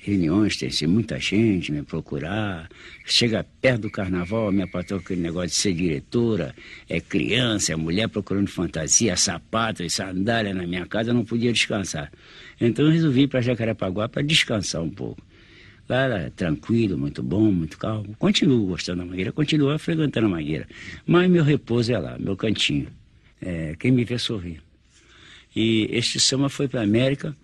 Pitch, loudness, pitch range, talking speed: 110 Hz, -23 LUFS, 90-125 Hz, 175 wpm